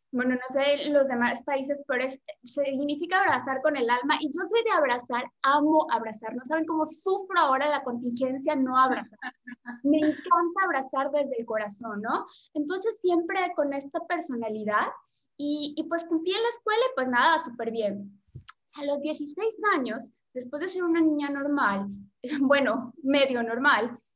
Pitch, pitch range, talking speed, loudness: 285 Hz, 250-315 Hz, 165 wpm, -27 LUFS